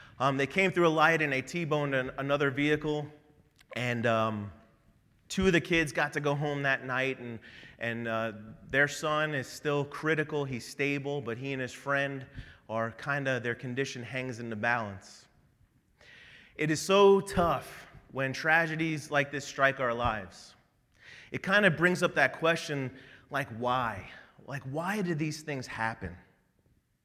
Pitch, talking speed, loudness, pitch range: 140 Hz, 165 wpm, -30 LUFS, 120-150 Hz